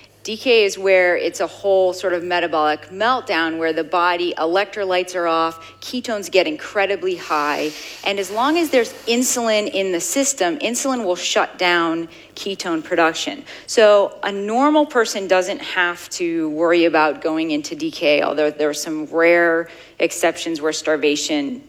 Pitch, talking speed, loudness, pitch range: 180 Hz, 150 wpm, -18 LUFS, 165-215 Hz